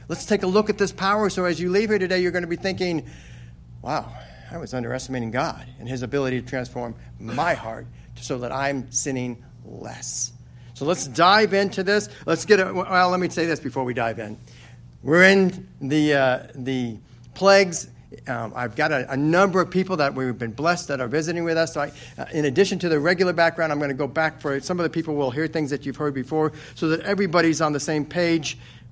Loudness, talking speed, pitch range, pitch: -22 LUFS, 225 wpm, 125-180 Hz, 150 Hz